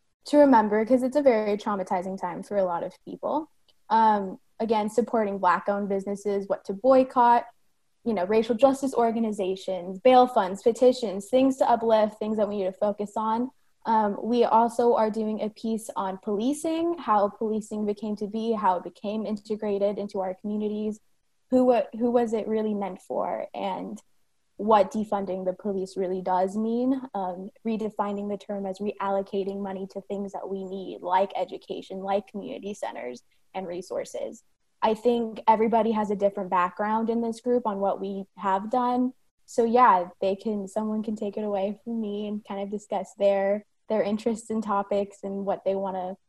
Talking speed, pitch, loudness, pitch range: 175 wpm, 210 Hz, -26 LUFS, 195-225 Hz